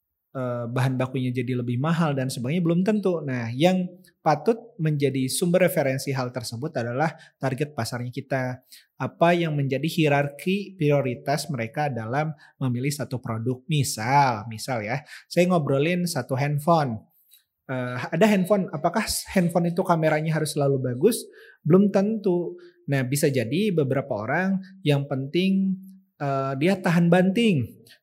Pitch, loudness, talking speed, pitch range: 145 Hz, -24 LUFS, 130 wpm, 130-175 Hz